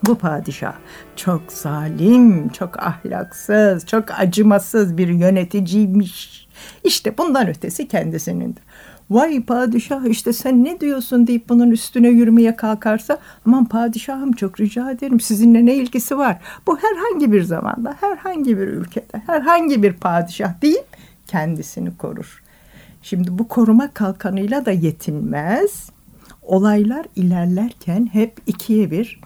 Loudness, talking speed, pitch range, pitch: -17 LUFS, 120 wpm, 190-245 Hz, 220 Hz